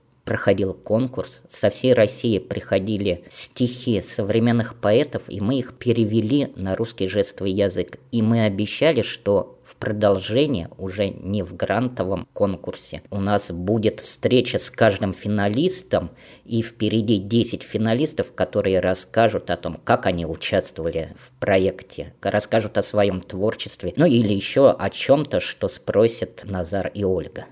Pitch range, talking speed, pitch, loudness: 95-115 Hz, 135 wpm, 105 Hz, -22 LUFS